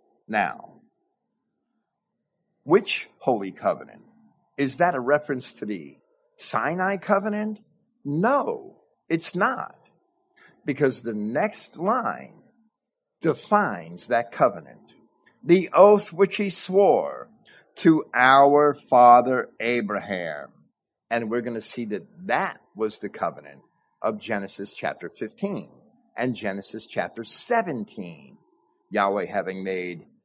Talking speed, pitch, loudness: 105 wpm, 145 Hz, -23 LUFS